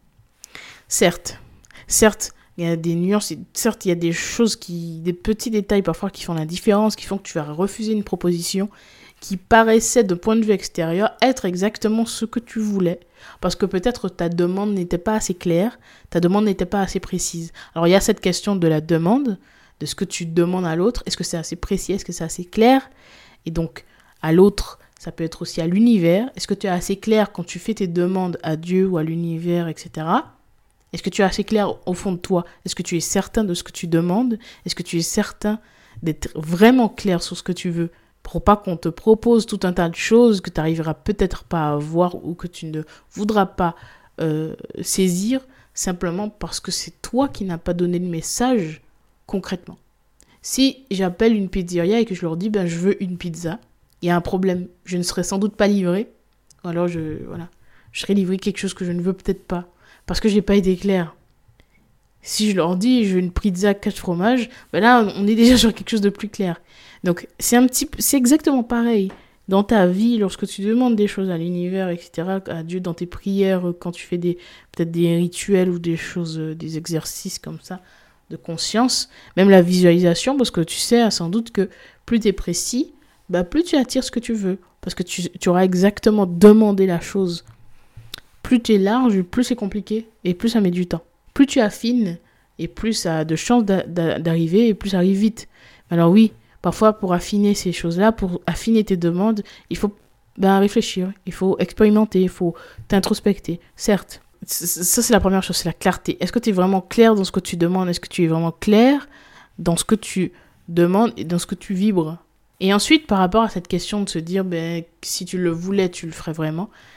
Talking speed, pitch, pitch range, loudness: 220 wpm, 185 Hz, 170-210 Hz, -20 LUFS